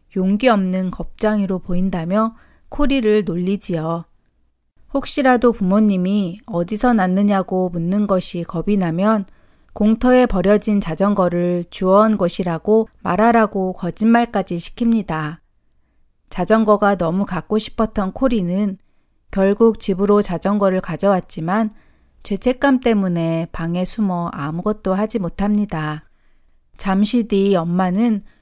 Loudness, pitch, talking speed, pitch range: -18 LUFS, 195 Hz, 265 characters per minute, 175-215 Hz